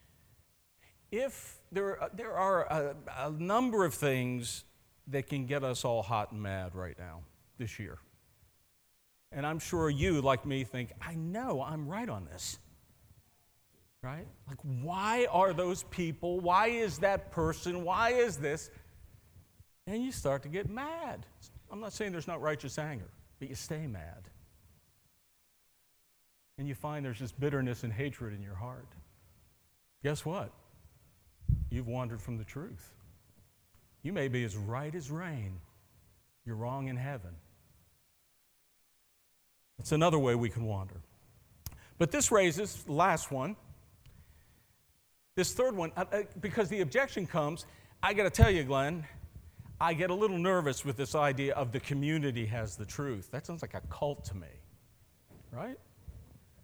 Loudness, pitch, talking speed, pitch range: -34 LUFS, 130 Hz, 150 wpm, 100-165 Hz